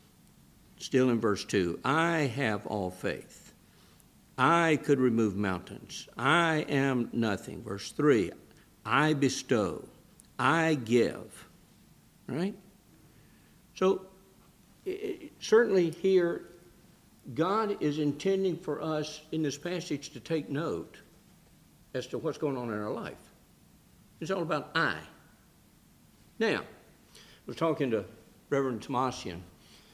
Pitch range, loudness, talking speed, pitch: 125-170 Hz, -30 LUFS, 110 wpm, 150 Hz